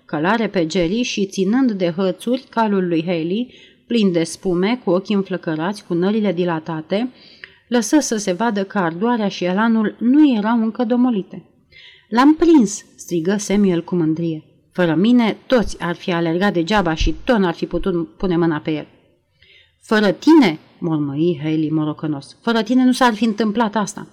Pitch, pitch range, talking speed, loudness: 195 Hz, 170-230 Hz, 165 wpm, -18 LUFS